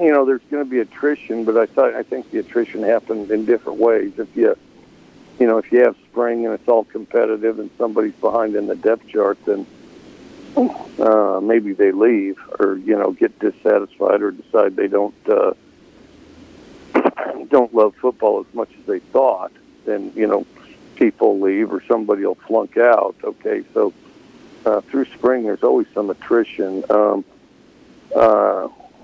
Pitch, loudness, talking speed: 125 Hz, -18 LUFS, 165 wpm